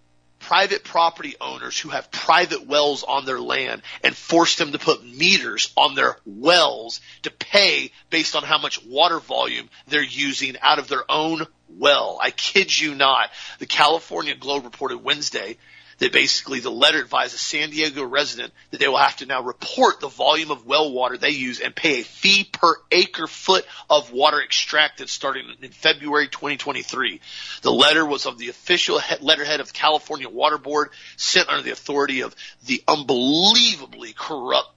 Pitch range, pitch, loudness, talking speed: 140-160 Hz, 150 Hz, -19 LUFS, 175 wpm